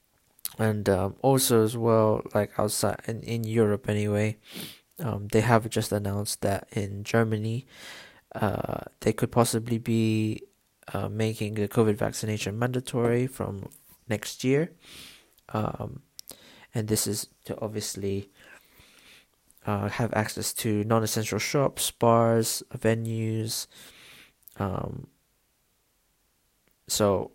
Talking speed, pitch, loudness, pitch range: 110 wpm, 110 Hz, -27 LUFS, 105-115 Hz